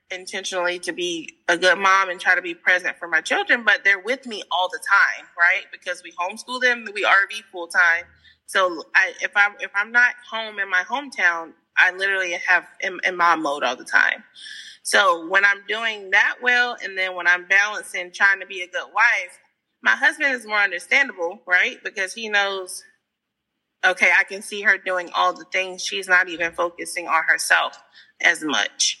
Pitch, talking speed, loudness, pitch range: 195 Hz, 190 wpm, -20 LUFS, 180-220 Hz